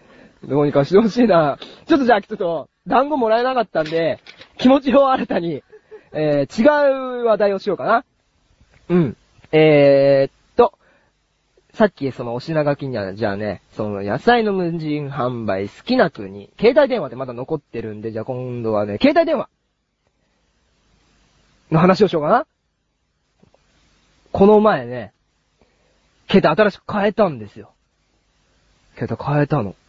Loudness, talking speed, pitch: -18 LUFS, 285 characters per minute, 155 Hz